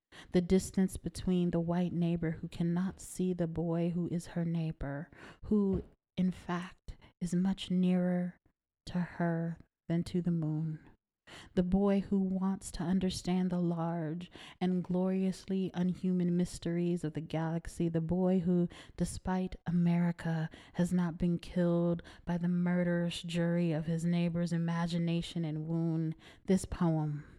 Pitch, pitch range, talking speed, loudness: 175 Hz, 170-180 Hz, 140 wpm, -34 LUFS